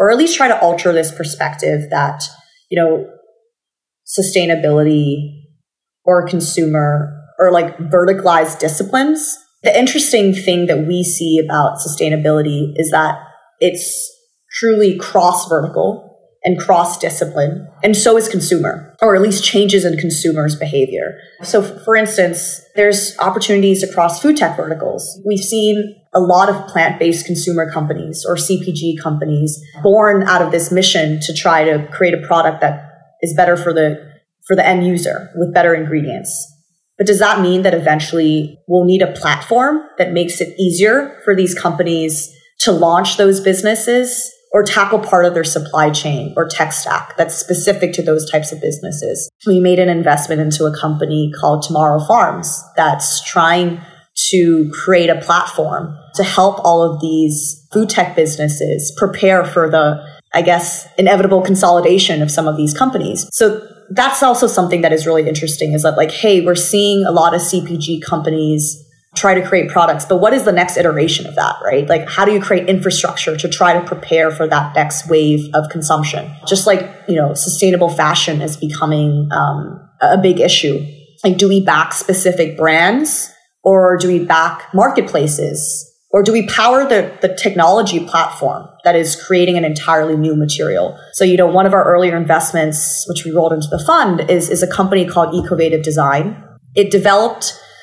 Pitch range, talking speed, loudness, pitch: 155-190 Hz, 165 wpm, -13 LUFS, 175 Hz